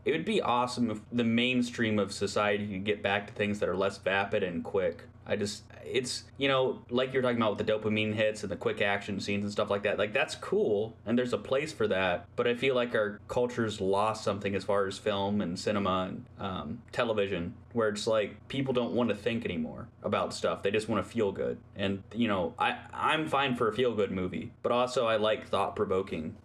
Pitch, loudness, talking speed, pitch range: 110 Hz, -31 LUFS, 230 wpm, 100-120 Hz